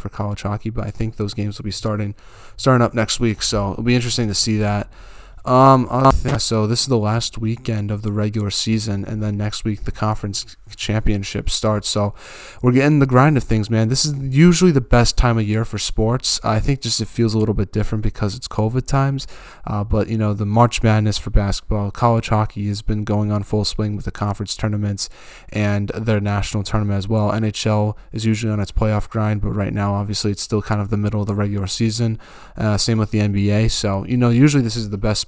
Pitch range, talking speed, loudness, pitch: 105-115 Hz, 225 wpm, -19 LUFS, 110 Hz